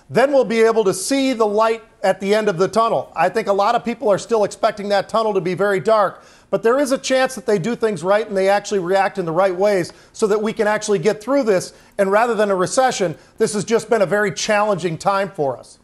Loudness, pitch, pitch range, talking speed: -18 LUFS, 210 Hz, 195-225 Hz, 265 wpm